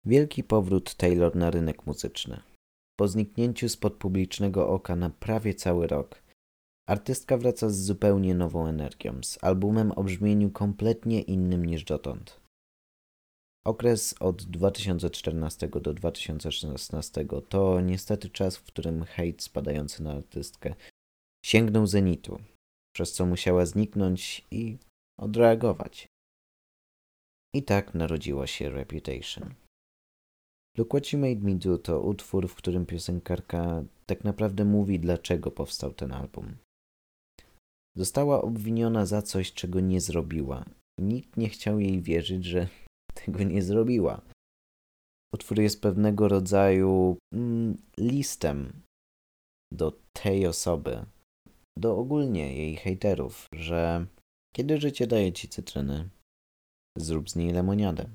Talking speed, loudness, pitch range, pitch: 115 wpm, -28 LUFS, 80-105 Hz, 95 Hz